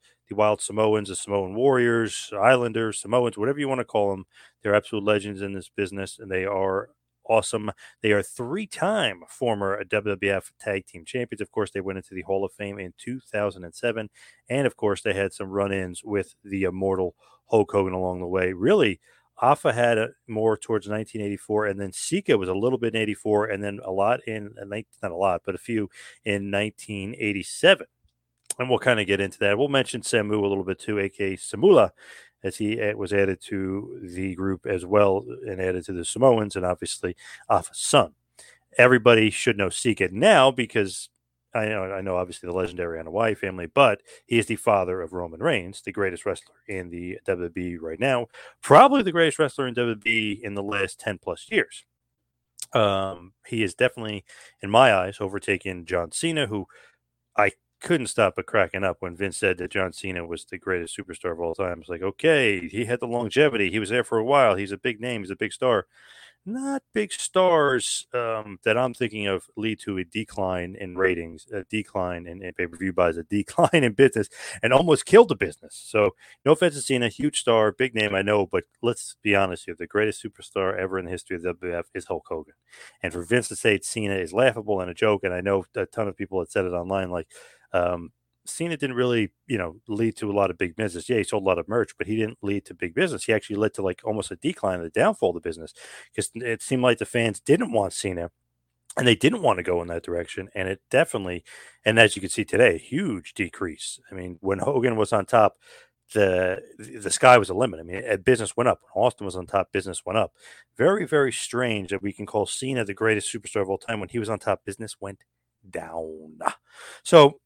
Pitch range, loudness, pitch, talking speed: 95-115 Hz, -24 LUFS, 100 Hz, 215 wpm